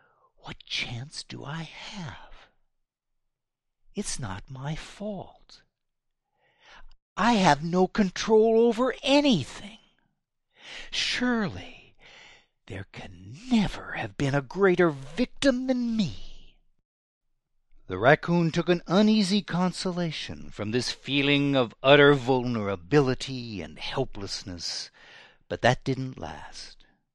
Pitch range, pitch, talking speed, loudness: 130-210 Hz, 155 Hz, 95 wpm, -25 LUFS